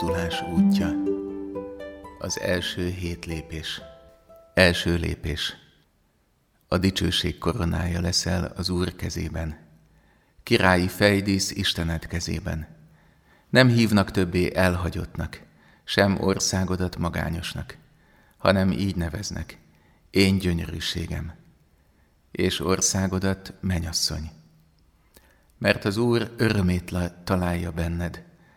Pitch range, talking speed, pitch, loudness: 80-95 Hz, 80 wpm, 90 Hz, -24 LUFS